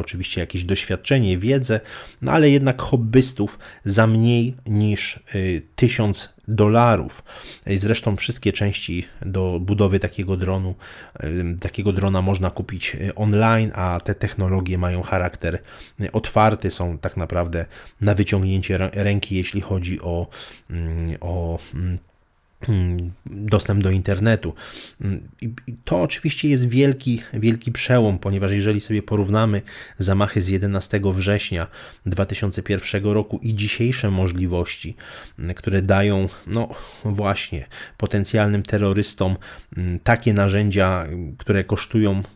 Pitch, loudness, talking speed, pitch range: 100 Hz, -21 LUFS, 105 wpm, 95-110 Hz